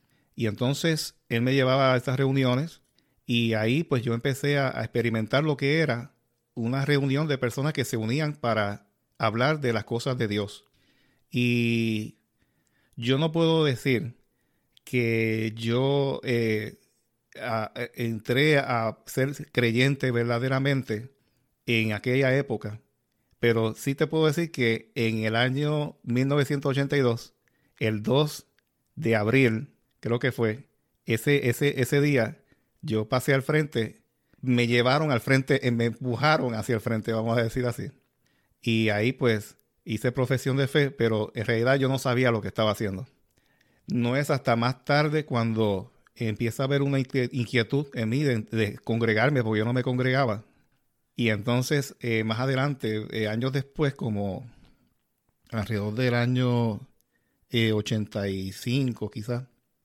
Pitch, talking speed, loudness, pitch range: 125 Hz, 140 wpm, -26 LUFS, 115-135 Hz